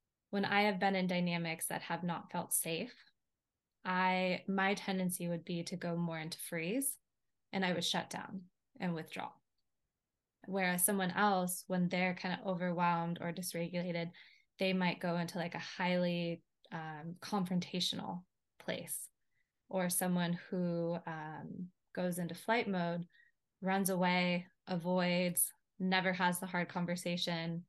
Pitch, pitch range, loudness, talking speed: 180 Hz, 170-185 Hz, -36 LUFS, 140 wpm